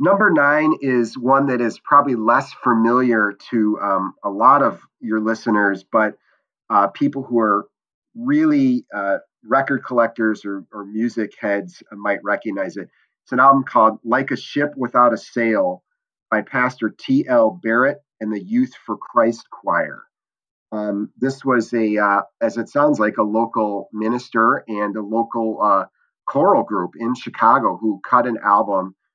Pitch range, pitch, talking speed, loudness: 110-140 Hz, 120 Hz, 155 wpm, -18 LUFS